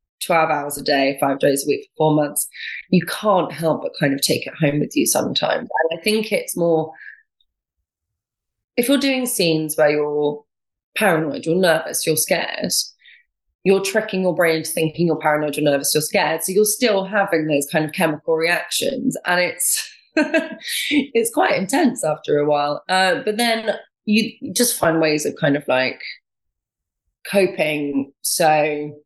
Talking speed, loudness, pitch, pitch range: 165 wpm, -19 LUFS, 160 Hz, 150-210 Hz